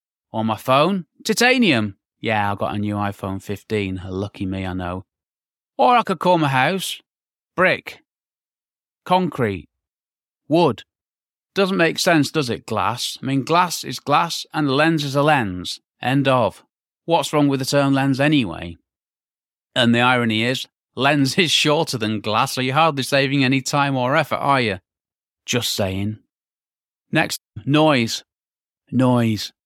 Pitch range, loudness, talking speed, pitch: 100-150 Hz, -19 LUFS, 150 wpm, 130 Hz